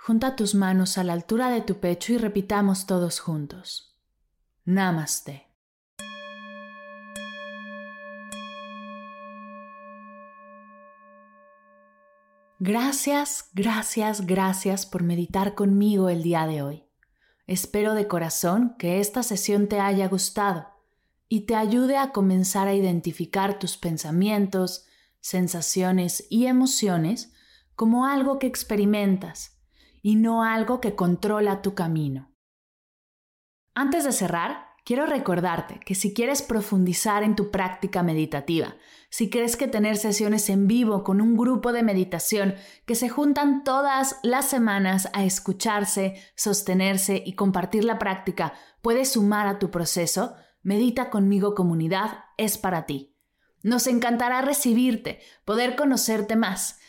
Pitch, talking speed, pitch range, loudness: 195 Hz, 115 wpm, 170-220 Hz, -24 LUFS